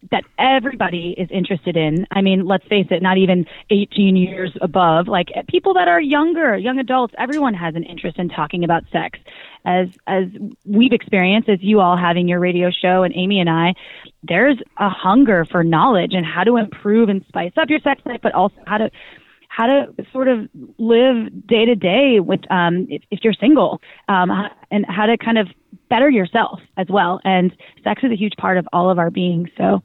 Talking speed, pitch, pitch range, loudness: 205 wpm, 195 Hz, 180-230 Hz, -17 LUFS